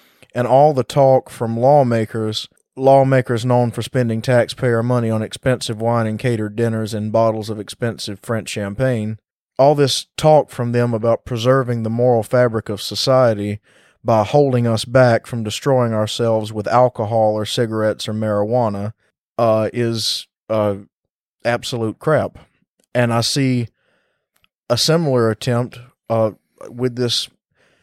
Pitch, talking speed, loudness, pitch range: 115 Hz, 135 wpm, -18 LUFS, 110-125 Hz